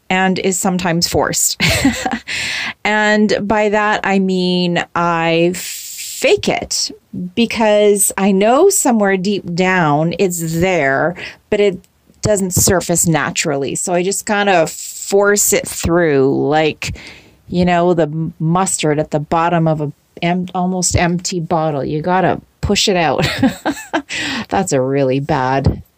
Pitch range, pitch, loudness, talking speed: 165-200 Hz, 180 Hz, -15 LUFS, 130 wpm